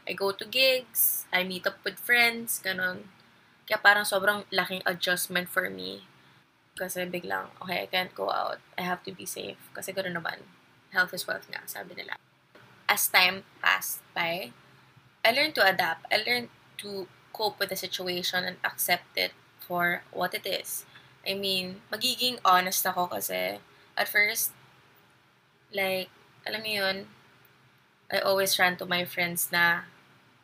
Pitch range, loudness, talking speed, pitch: 180-200 Hz, -27 LUFS, 155 wpm, 185 Hz